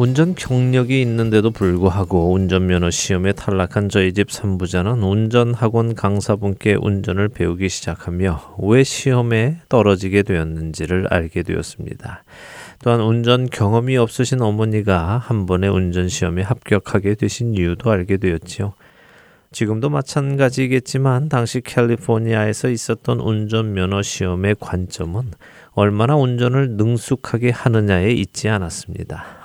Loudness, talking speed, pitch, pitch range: -18 LUFS, 320 characters per minute, 105 Hz, 95-120 Hz